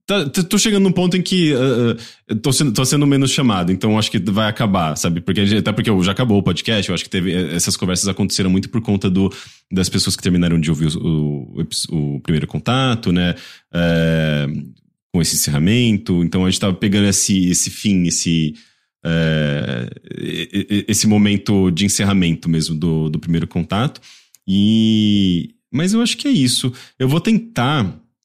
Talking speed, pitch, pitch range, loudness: 180 wpm, 100 Hz, 85-120 Hz, -17 LUFS